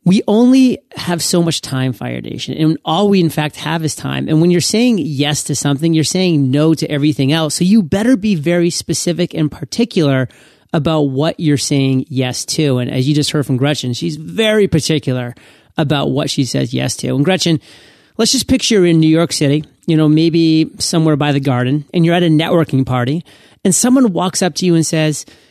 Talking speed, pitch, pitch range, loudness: 210 wpm, 155 Hz, 145-175 Hz, -14 LUFS